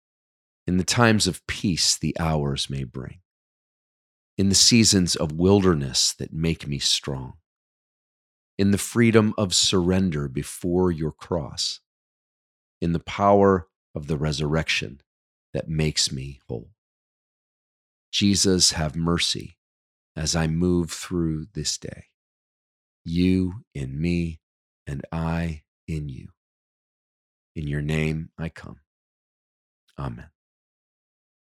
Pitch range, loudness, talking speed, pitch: 70-90 Hz, -22 LUFS, 110 wpm, 80 Hz